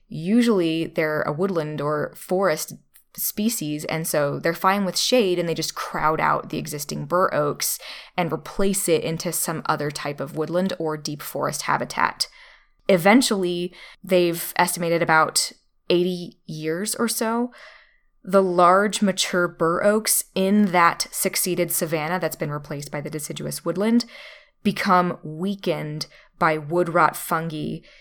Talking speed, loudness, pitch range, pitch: 140 wpm, -22 LUFS, 160-195 Hz, 175 Hz